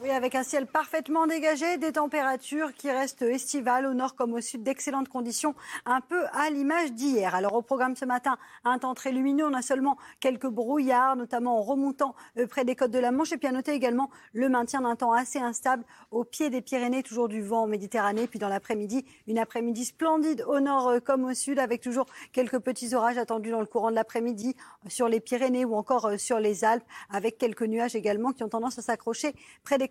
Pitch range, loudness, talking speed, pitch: 235-270 Hz, -28 LUFS, 215 wpm, 255 Hz